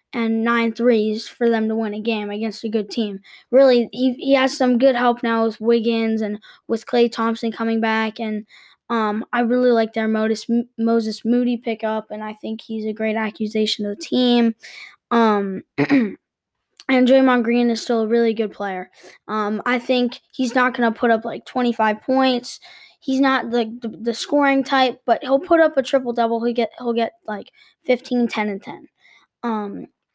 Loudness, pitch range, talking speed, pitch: -20 LUFS, 220-250 Hz, 185 wpm, 230 Hz